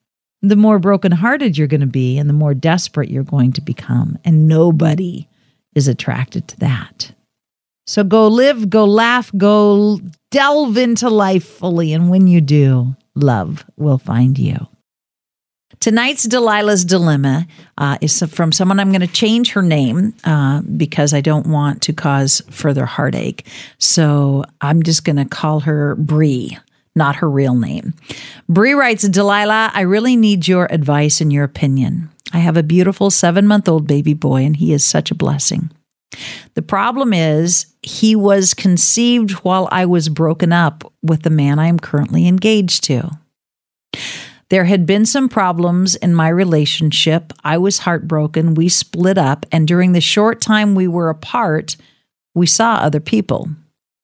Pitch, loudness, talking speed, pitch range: 165 Hz, -14 LUFS, 160 wpm, 150-195 Hz